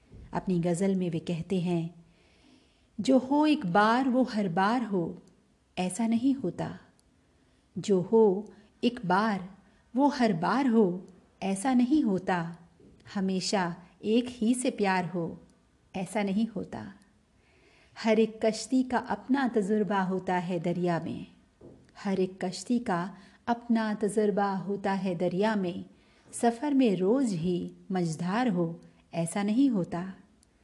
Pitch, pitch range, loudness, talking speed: 200 Hz, 180-230 Hz, -29 LUFS, 130 wpm